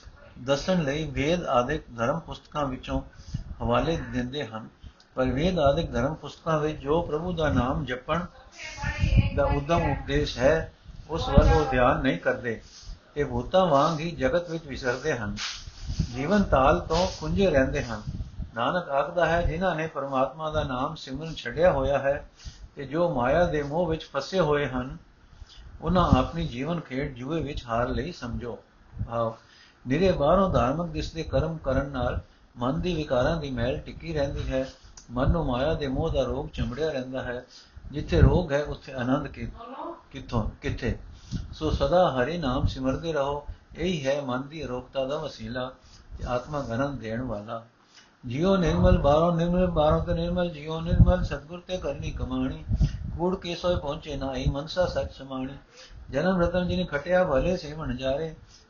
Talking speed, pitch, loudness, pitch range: 160 wpm, 140 Hz, -27 LUFS, 125-160 Hz